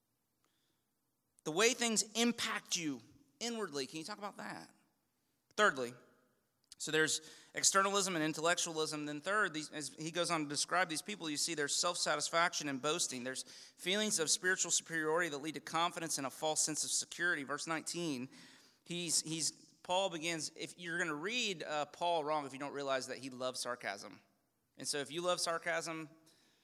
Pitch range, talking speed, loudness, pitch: 145-175 Hz, 170 wpm, -36 LUFS, 160 Hz